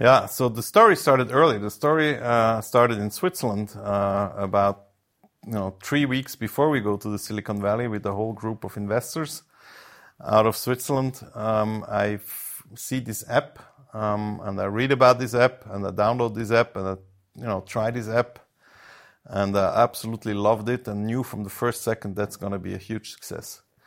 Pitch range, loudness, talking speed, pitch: 105-125 Hz, -24 LUFS, 190 wpm, 110 Hz